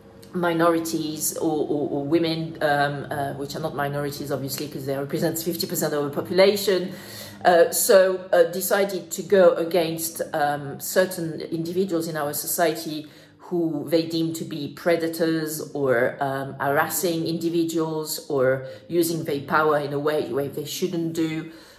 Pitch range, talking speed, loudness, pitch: 145-170 Hz, 145 wpm, -23 LUFS, 165 Hz